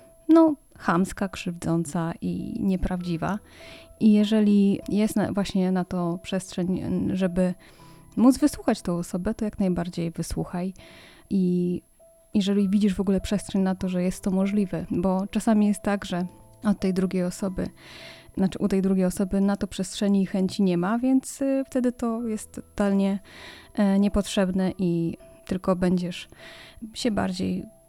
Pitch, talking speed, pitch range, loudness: 195 Hz, 140 wpm, 180-210 Hz, -25 LUFS